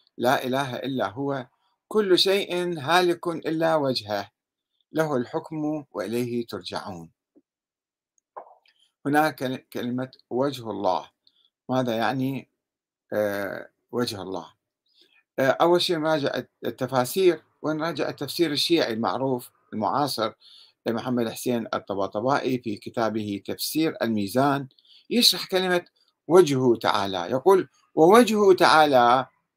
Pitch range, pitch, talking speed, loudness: 120-160 Hz, 130 Hz, 90 wpm, -24 LUFS